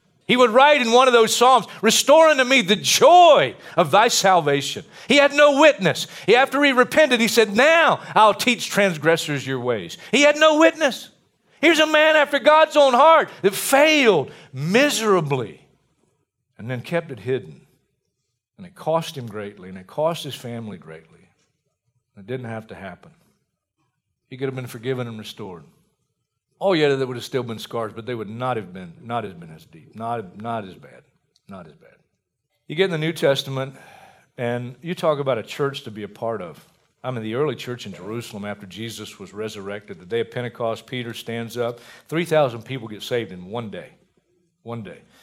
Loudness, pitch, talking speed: -18 LUFS, 140 Hz, 190 wpm